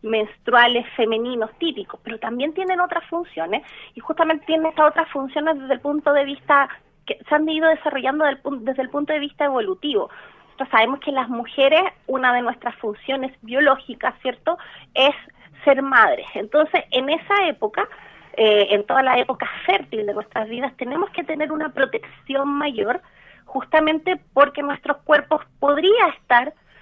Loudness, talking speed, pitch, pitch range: -20 LUFS, 155 wpm, 285 Hz, 255-315 Hz